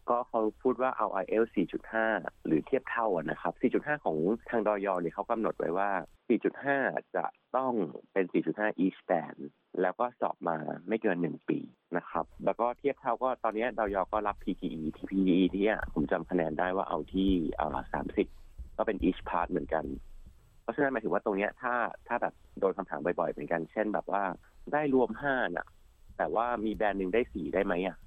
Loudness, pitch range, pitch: -32 LUFS, 95-120 Hz, 110 Hz